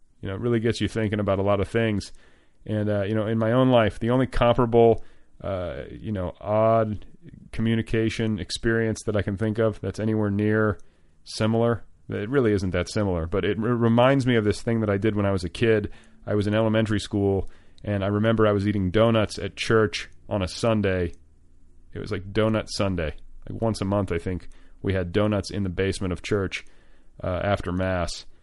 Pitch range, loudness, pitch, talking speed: 90-110 Hz, -24 LUFS, 105 Hz, 205 wpm